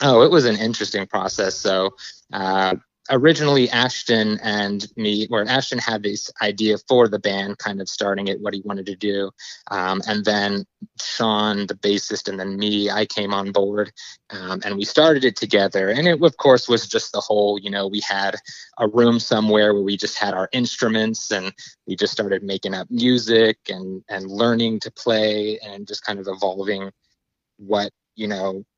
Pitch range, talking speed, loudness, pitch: 100-110 Hz, 185 wpm, -20 LUFS, 105 Hz